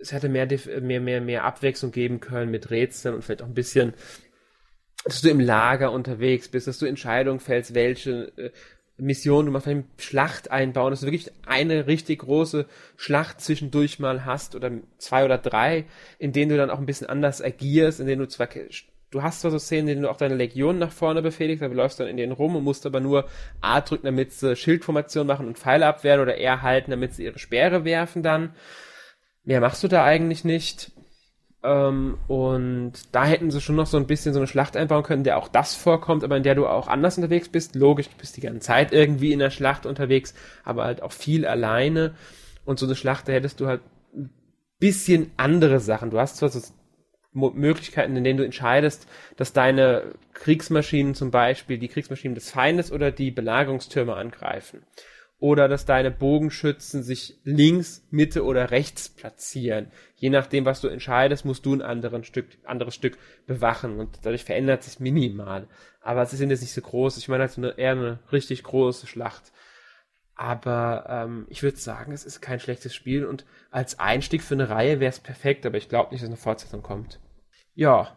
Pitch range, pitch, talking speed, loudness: 125-150 Hz, 135 Hz, 195 wpm, -23 LUFS